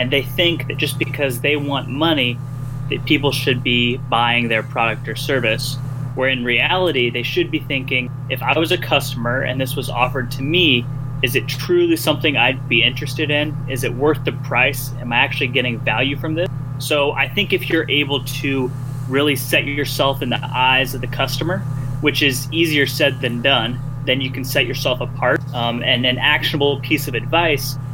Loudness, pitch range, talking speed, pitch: -18 LUFS, 130-145 Hz, 195 wpm, 135 Hz